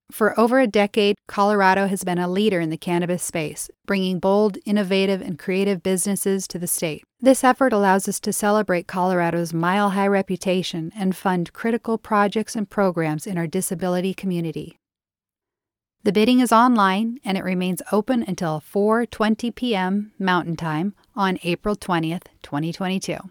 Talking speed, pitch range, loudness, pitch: 150 wpm, 180-210 Hz, -21 LUFS, 195 Hz